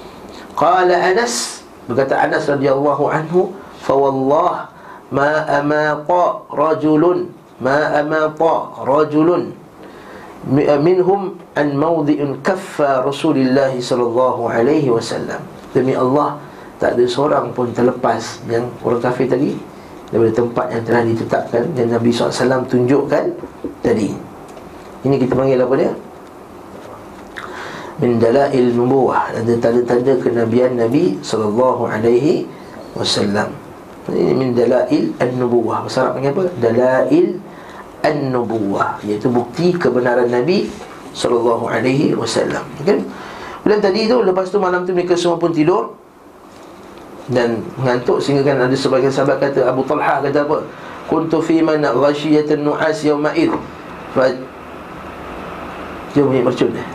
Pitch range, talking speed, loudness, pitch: 120-155 Hz, 115 wpm, -16 LUFS, 135 Hz